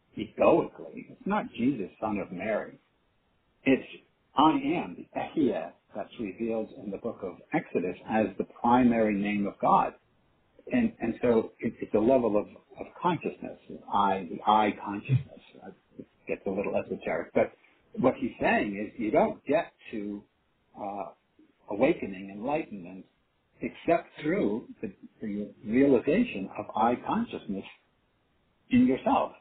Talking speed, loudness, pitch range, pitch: 135 wpm, -29 LUFS, 100-135 Hz, 110 Hz